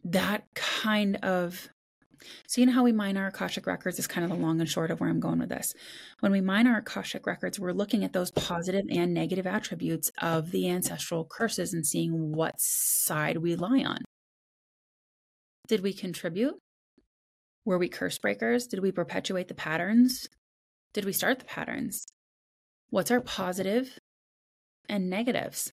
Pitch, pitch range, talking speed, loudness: 190 Hz, 170-225 Hz, 170 wpm, -29 LUFS